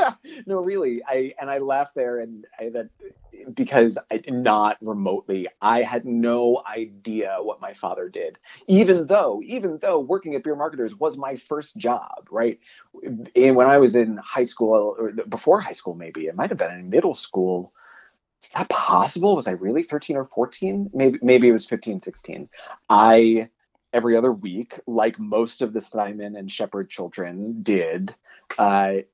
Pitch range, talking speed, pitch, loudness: 105-150 Hz, 175 wpm, 120 Hz, -21 LUFS